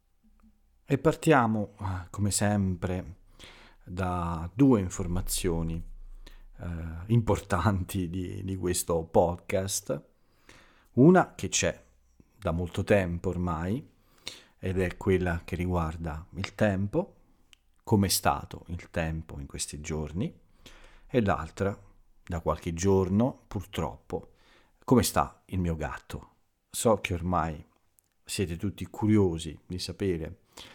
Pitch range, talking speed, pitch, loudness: 85-100 Hz, 105 wpm, 90 Hz, -29 LUFS